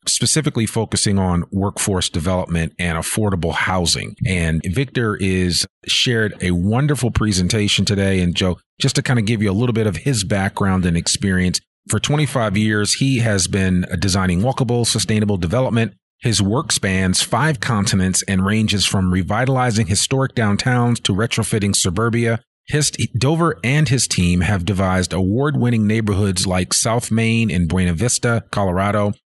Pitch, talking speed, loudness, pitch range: 105 Hz, 145 wpm, -18 LUFS, 95-120 Hz